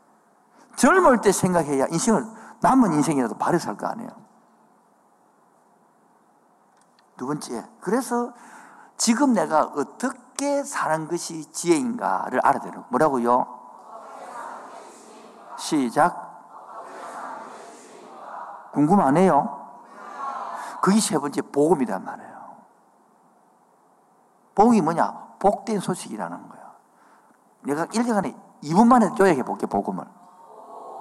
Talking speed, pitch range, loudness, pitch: 205 characters per minute, 180-245 Hz, -22 LUFS, 220 Hz